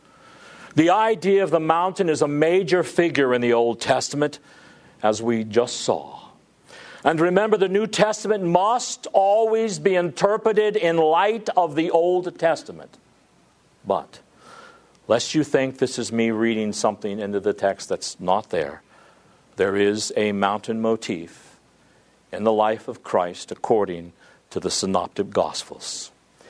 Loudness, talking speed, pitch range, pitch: -22 LUFS, 140 wpm, 115-190 Hz, 155 Hz